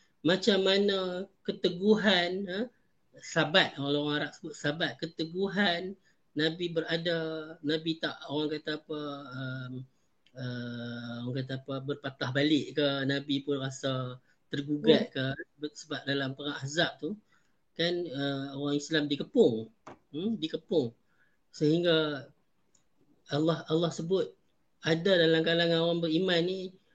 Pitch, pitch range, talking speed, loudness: 155 Hz, 140-170 Hz, 115 wpm, -30 LUFS